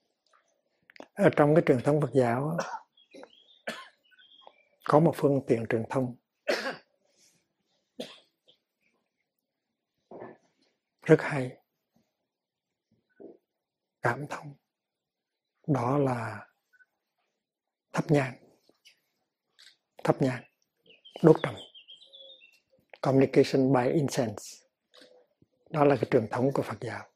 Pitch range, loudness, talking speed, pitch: 130-160 Hz, -27 LUFS, 80 wpm, 140 Hz